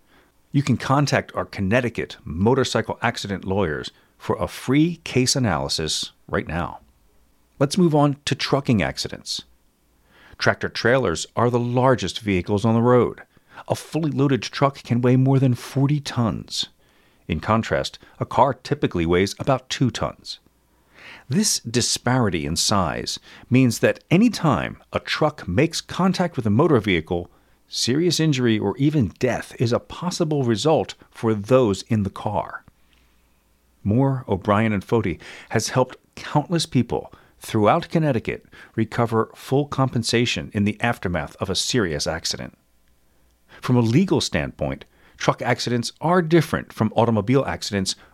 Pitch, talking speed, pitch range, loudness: 120 Hz, 135 wpm, 100-140 Hz, -22 LUFS